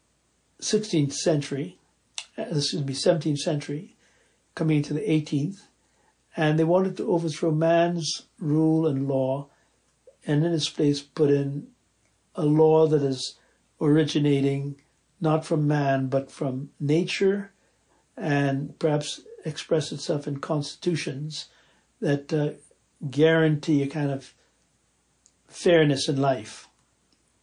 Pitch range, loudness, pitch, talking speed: 140-165 Hz, -25 LUFS, 150 Hz, 115 wpm